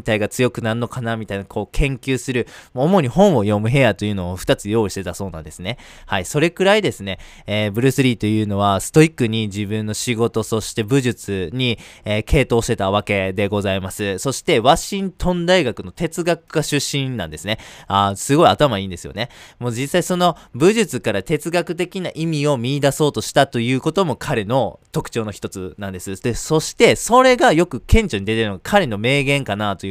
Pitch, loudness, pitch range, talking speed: 120 Hz, -19 LUFS, 105-150 Hz, 400 characters per minute